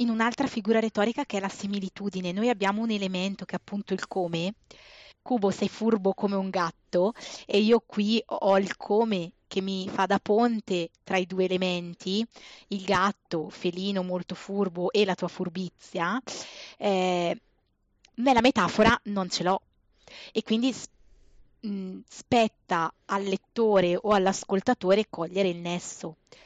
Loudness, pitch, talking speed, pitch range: -27 LUFS, 195 Hz, 145 wpm, 185-220 Hz